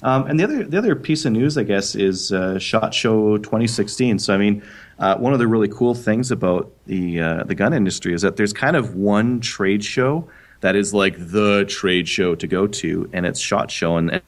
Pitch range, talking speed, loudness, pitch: 95-120 Hz, 225 wpm, -19 LUFS, 105 Hz